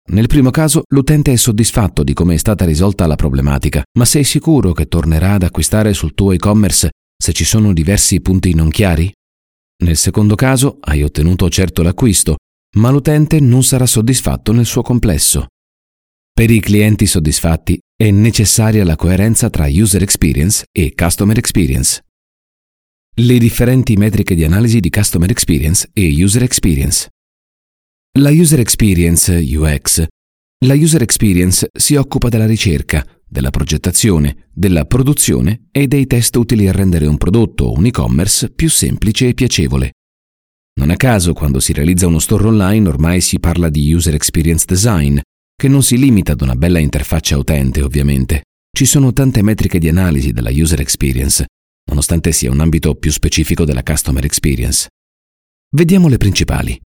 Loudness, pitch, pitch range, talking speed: -12 LUFS, 90 Hz, 75-115 Hz, 155 wpm